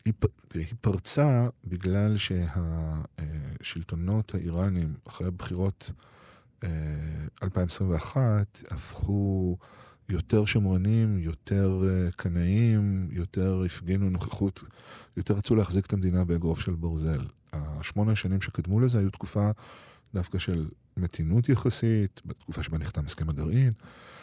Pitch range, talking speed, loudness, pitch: 85-105 Hz, 95 wpm, -28 LUFS, 95 Hz